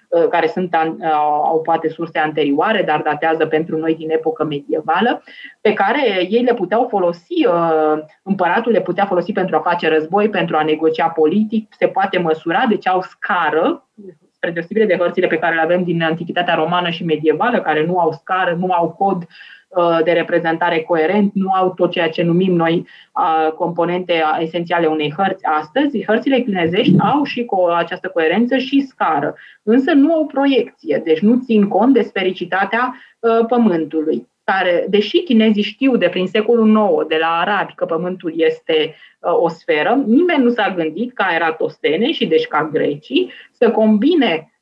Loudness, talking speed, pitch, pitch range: -16 LUFS, 165 wpm, 180 Hz, 165-220 Hz